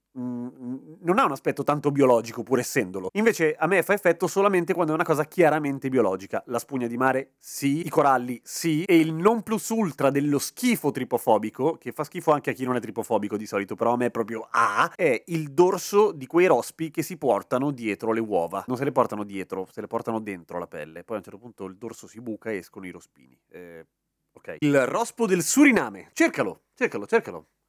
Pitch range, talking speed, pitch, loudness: 115-165 Hz, 215 wpm, 135 Hz, -24 LUFS